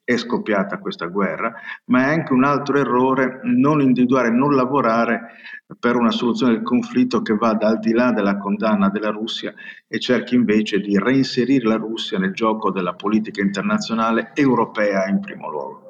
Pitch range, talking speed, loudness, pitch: 105-130 Hz, 165 wpm, -19 LUFS, 115 Hz